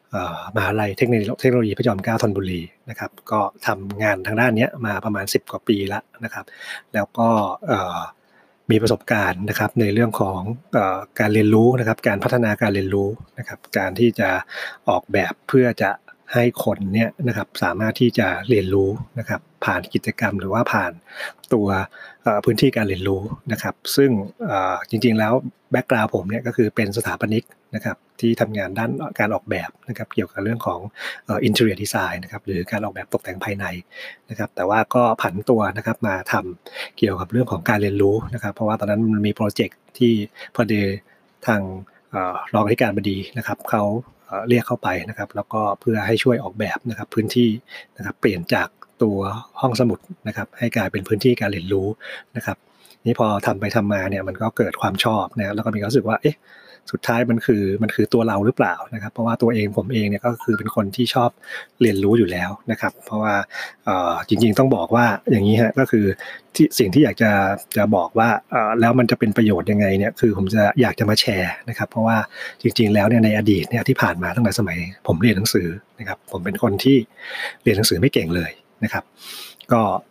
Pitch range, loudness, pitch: 100-120 Hz, -20 LUFS, 110 Hz